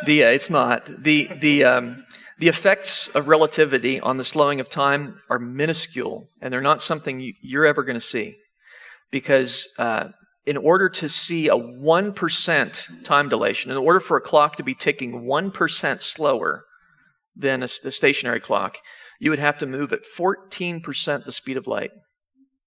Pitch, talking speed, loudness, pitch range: 150 Hz, 165 wpm, -21 LUFS, 135-170 Hz